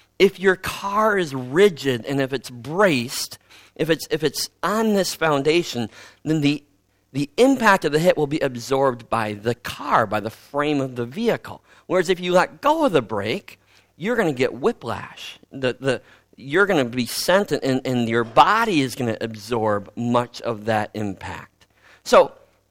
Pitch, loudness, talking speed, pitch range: 135 Hz, -21 LUFS, 180 wpm, 120-180 Hz